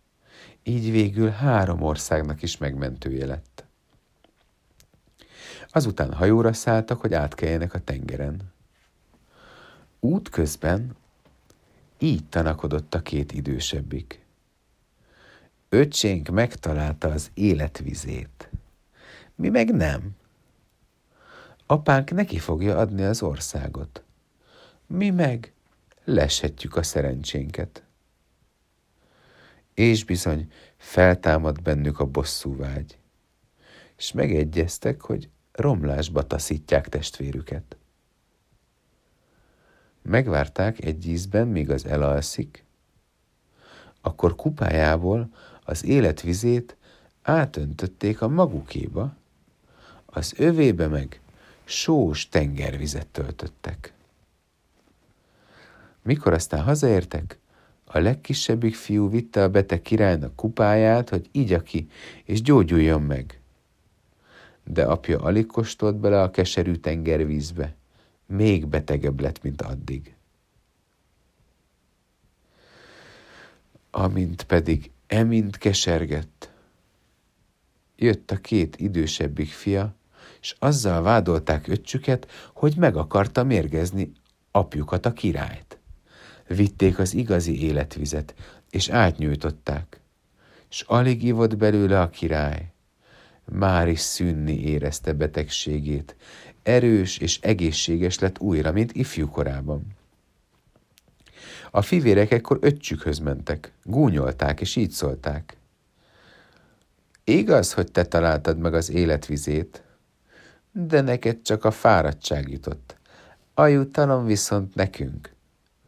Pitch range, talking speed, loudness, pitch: 75-110 Hz, 90 wpm, -23 LUFS, 85 Hz